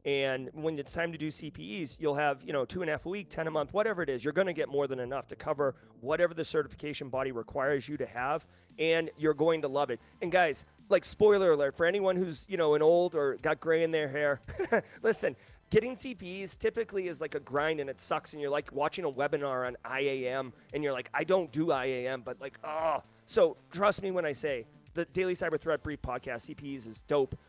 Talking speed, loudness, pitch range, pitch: 235 wpm, -32 LUFS, 140-180 Hz, 155 Hz